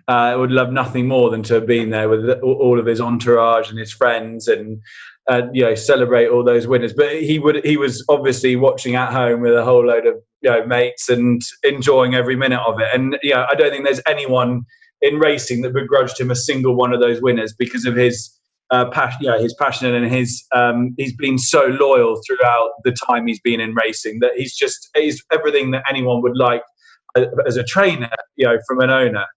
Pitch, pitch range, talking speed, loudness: 125 Hz, 120-140 Hz, 215 wpm, -16 LUFS